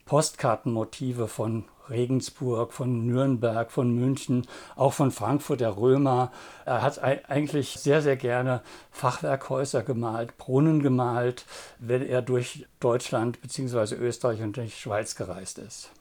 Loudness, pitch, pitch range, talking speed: -27 LUFS, 125 Hz, 120-135 Hz, 125 wpm